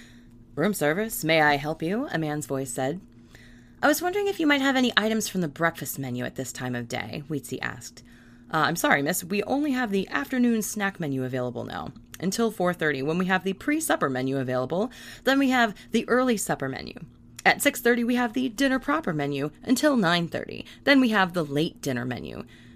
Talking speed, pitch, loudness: 200 wpm, 170 Hz, -25 LUFS